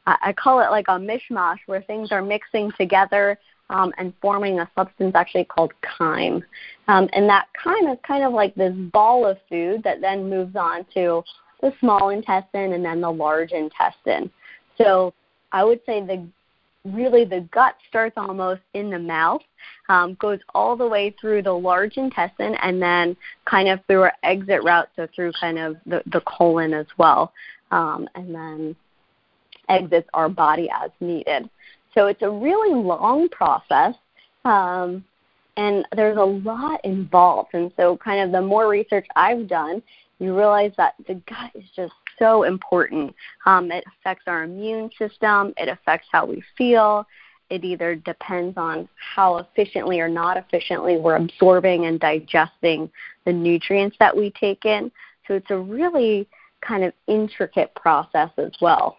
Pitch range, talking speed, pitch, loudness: 175-210 Hz, 165 wpm, 190 Hz, -20 LUFS